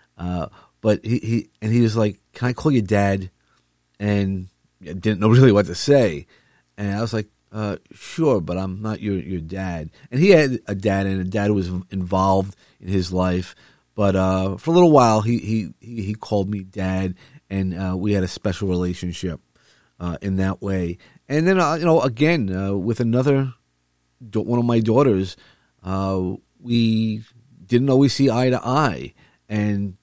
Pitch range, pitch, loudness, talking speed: 95-120 Hz, 100 Hz, -21 LUFS, 185 wpm